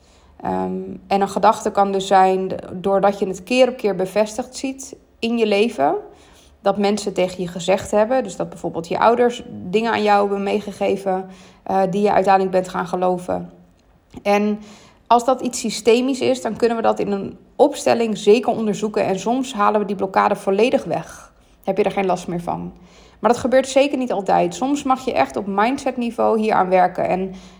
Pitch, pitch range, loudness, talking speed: 205 Hz, 190-230 Hz, -19 LUFS, 190 wpm